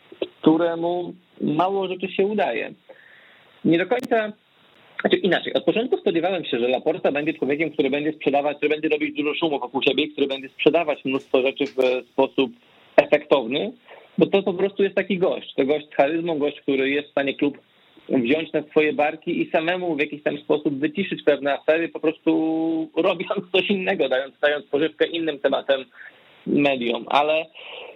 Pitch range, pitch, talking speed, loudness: 140-175 Hz, 155 Hz, 165 wpm, -22 LUFS